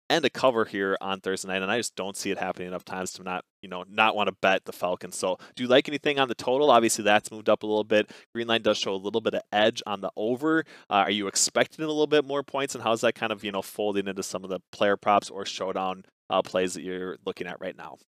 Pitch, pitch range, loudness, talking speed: 105 Hz, 95-115 Hz, -26 LUFS, 285 wpm